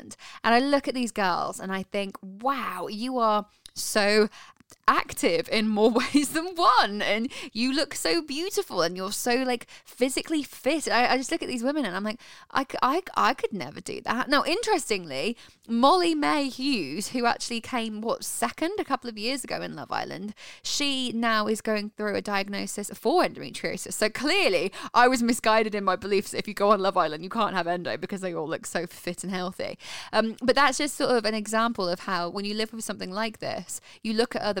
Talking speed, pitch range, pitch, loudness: 210 wpm, 205-270 Hz, 225 Hz, -26 LUFS